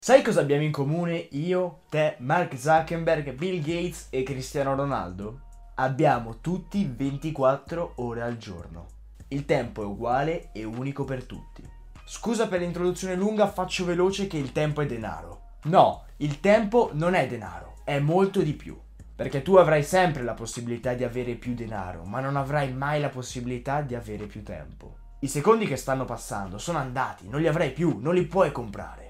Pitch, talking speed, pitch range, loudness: 140 Hz, 175 wpm, 120-170 Hz, -26 LUFS